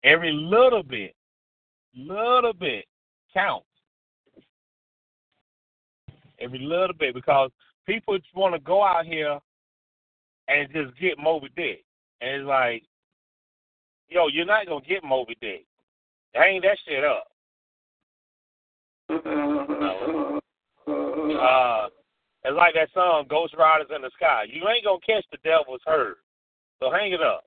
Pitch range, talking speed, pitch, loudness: 135-195 Hz, 130 wpm, 160 Hz, -23 LUFS